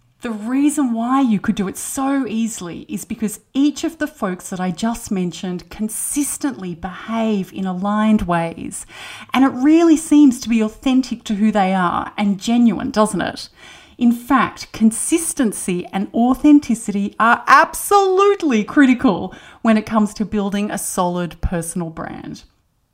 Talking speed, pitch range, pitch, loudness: 145 wpm, 195-265 Hz, 220 Hz, -17 LUFS